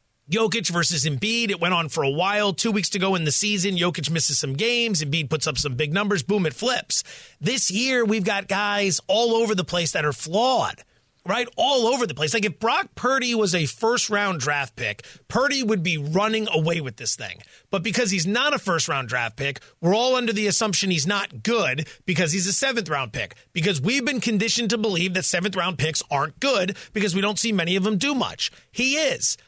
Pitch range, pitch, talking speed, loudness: 155-220 Hz, 195 Hz, 225 wpm, -22 LUFS